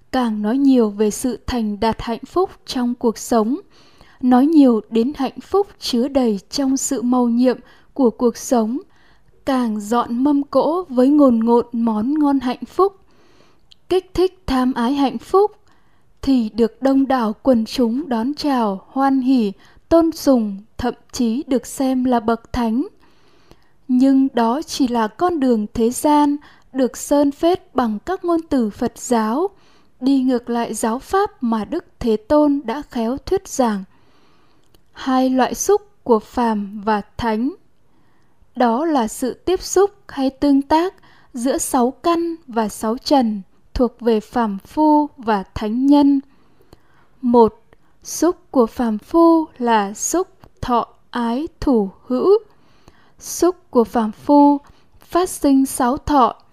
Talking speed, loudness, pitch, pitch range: 150 wpm, -18 LUFS, 255 Hz, 230-290 Hz